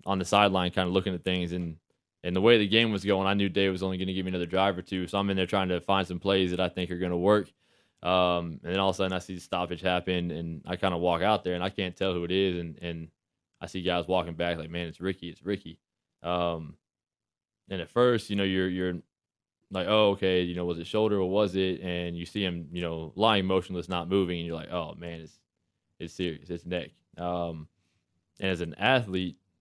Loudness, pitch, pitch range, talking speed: -28 LUFS, 90 Hz, 85-95 Hz, 255 wpm